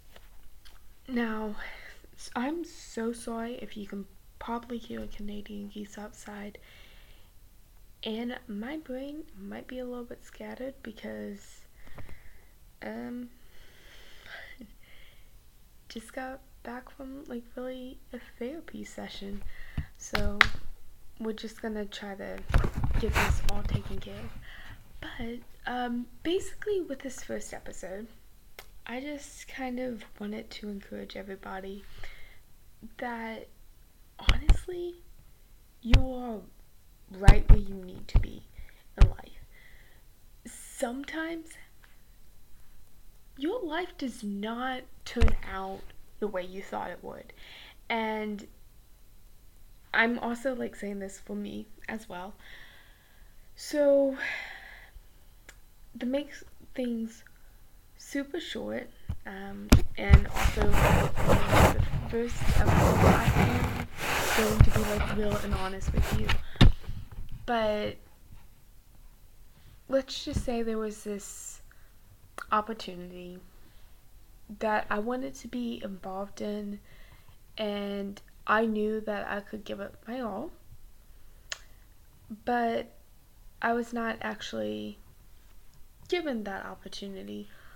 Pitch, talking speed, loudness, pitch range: 215 Hz, 105 wpm, -31 LUFS, 185-250 Hz